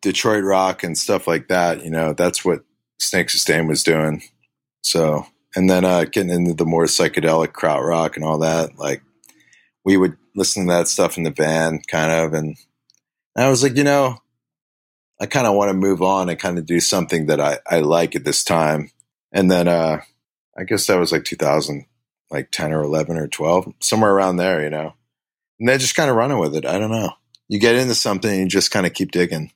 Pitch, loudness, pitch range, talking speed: 90 Hz, -18 LUFS, 80-100 Hz, 215 wpm